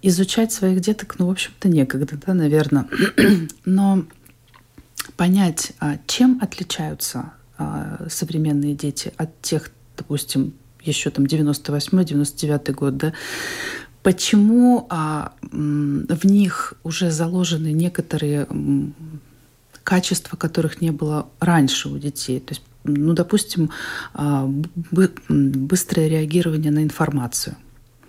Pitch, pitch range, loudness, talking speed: 155 Hz, 145-185 Hz, -20 LUFS, 95 wpm